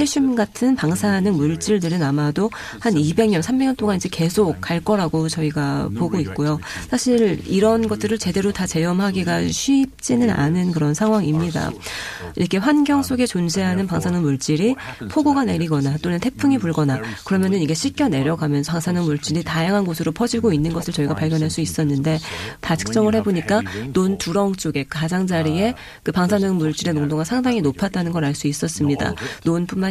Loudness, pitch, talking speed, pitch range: -20 LUFS, 180 Hz, 370 characters per minute, 155-215 Hz